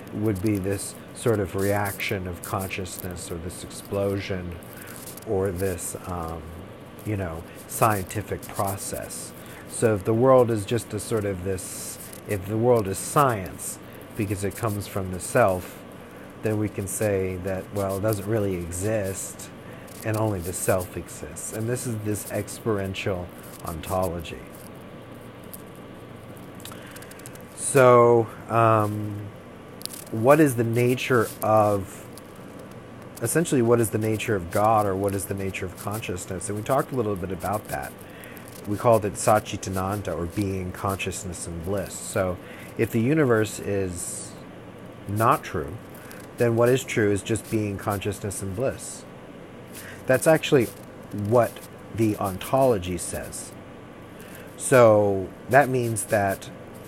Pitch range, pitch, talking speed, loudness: 95-110 Hz, 100 Hz, 130 wpm, -25 LUFS